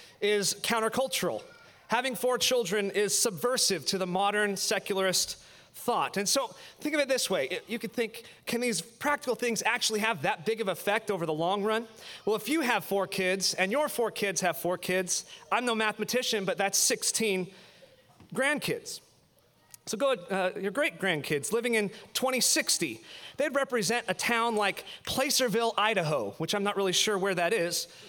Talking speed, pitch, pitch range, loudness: 170 wpm, 215 Hz, 195-240 Hz, -28 LUFS